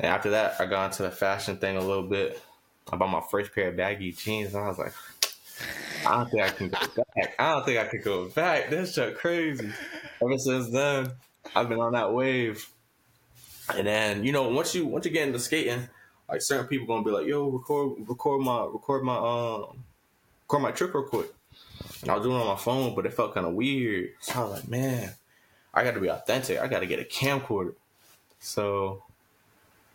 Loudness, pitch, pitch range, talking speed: -28 LUFS, 115 Hz, 100-130 Hz, 215 wpm